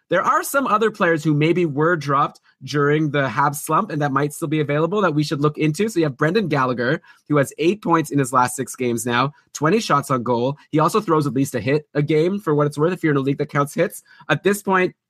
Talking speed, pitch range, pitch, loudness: 265 wpm, 140-170 Hz, 150 Hz, -20 LUFS